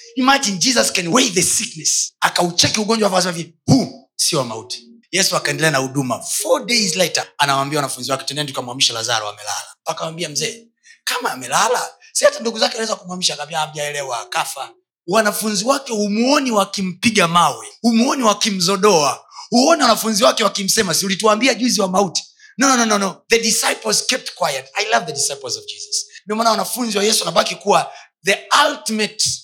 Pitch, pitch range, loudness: 205 Hz, 165-235 Hz, -17 LUFS